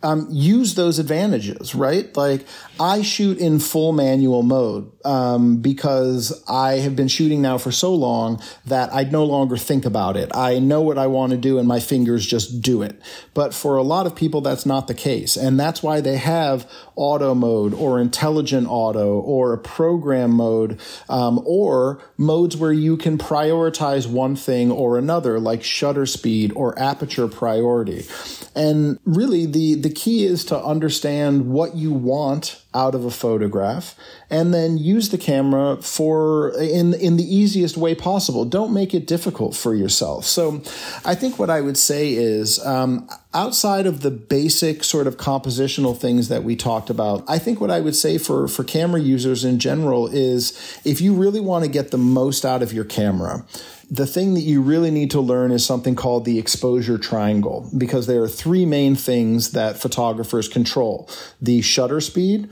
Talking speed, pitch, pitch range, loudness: 180 wpm, 135 Hz, 120-160 Hz, -19 LUFS